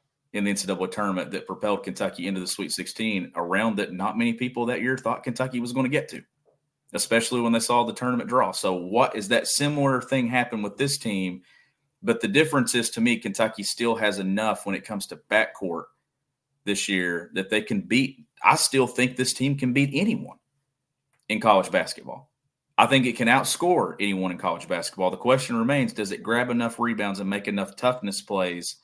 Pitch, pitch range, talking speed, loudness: 120 Hz, 100-130 Hz, 200 wpm, -24 LUFS